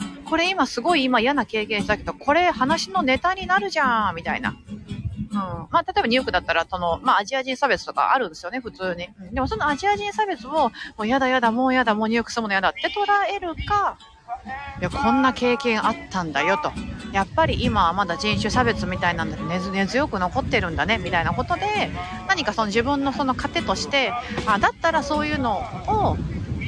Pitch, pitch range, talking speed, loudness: 260 Hz, 215-320 Hz, 420 characters per minute, -22 LUFS